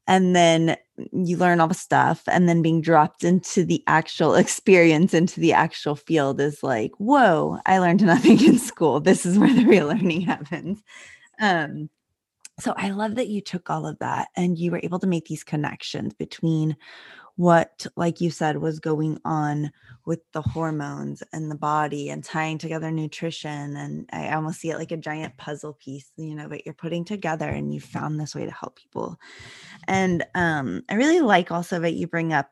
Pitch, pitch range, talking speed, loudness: 165 Hz, 150-180 Hz, 190 wpm, -22 LUFS